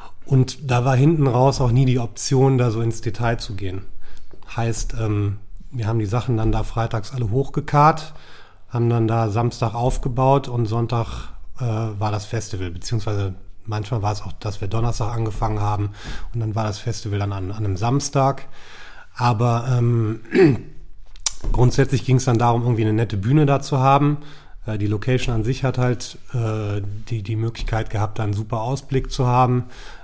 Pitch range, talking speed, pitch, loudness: 105-130 Hz, 170 wpm, 115 Hz, -21 LUFS